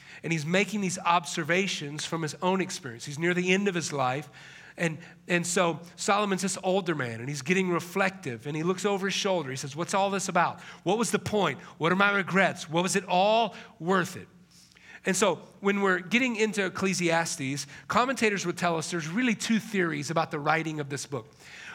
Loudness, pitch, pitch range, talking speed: -28 LUFS, 175 Hz, 160-195 Hz, 205 wpm